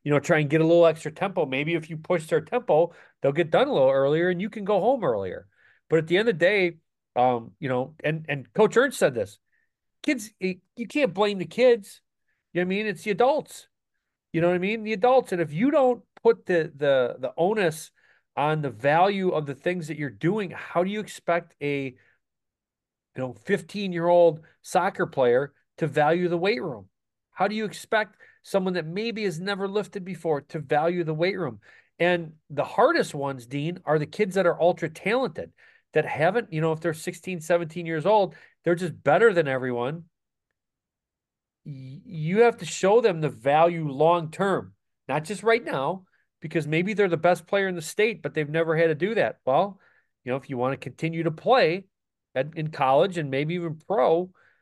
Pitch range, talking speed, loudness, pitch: 155-200 Hz, 205 wpm, -25 LUFS, 170 Hz